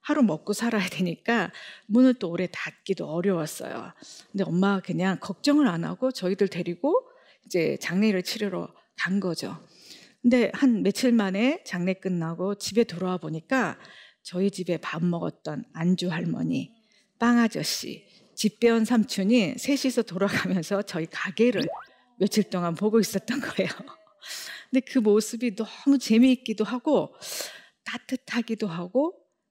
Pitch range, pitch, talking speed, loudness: 185-240 Hz, 210 Hz, 290 characters per minute, -26 LUFS